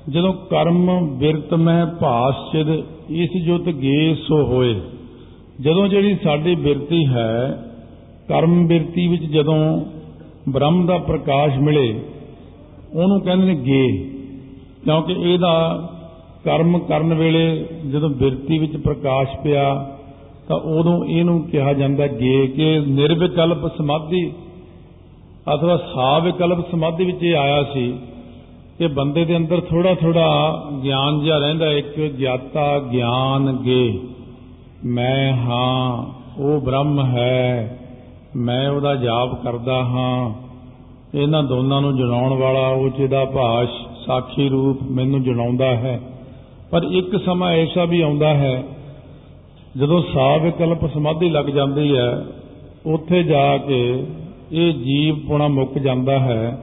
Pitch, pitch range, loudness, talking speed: 145 Hz, 130-165 Hz, -18 LUFS, 115 wpm